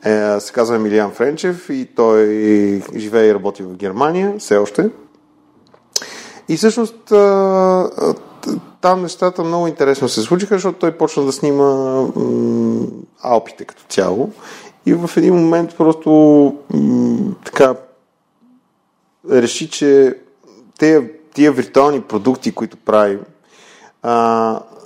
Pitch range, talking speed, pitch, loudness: 115-180 Hz, 115 wpm, 145 Hz, -15 LUFS